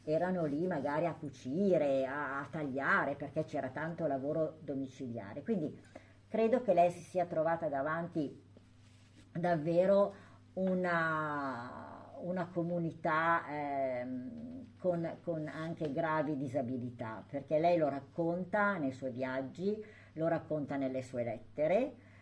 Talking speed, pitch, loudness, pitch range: 115 wpm, 155 Hz, -35 LUFS, 135-175 Hz